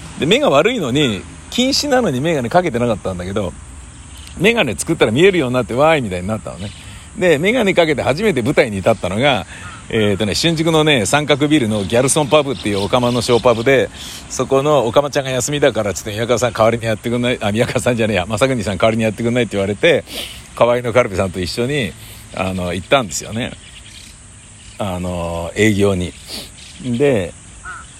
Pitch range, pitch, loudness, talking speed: 100-130 Hz, 115 Hz, -16 LUFS, 435 characters per minute